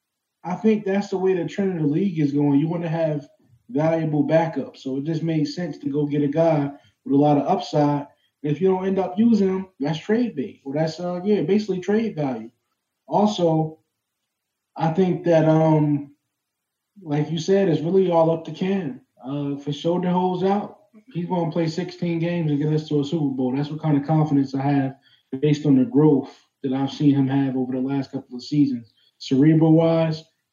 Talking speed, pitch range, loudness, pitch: 210 wpm, 140-175 Hz, -22 LUFS, 155 Hz